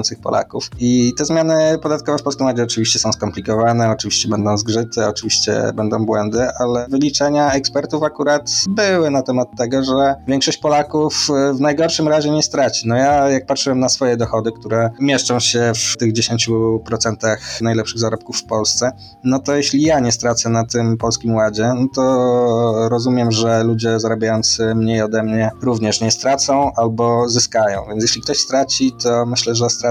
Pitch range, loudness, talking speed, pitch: 115-135 Hz, -16 LUFS, 165 wpm, 120 Hz